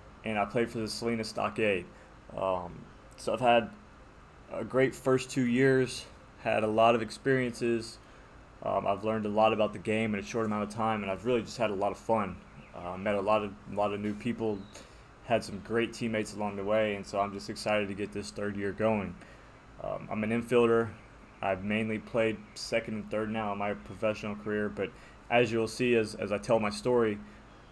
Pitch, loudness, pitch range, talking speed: 110 Hz, -31 LUFS, 105-115 Hz, 210 wpm